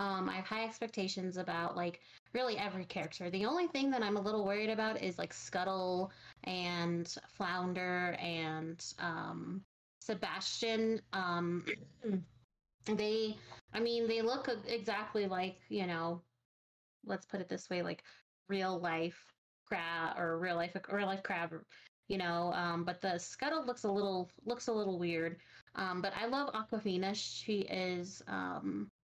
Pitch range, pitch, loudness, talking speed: 170-215 Hz, 185 Hz, -38 LUFS, 150 wpm